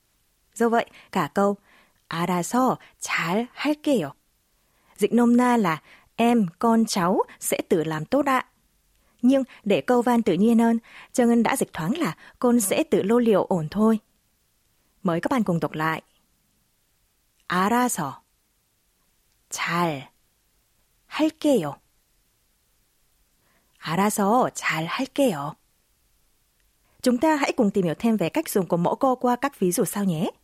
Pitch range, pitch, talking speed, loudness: 175-245 Hz, 220 Hz, 140 wpm, -23 LUFS